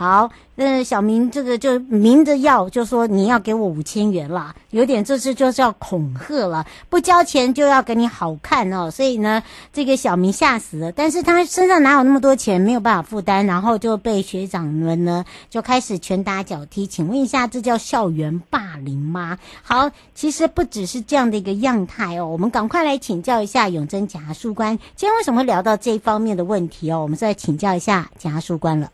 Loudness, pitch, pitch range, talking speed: -18 LUFS, 220 Hz, 180-260 Hz, 310 characters per minute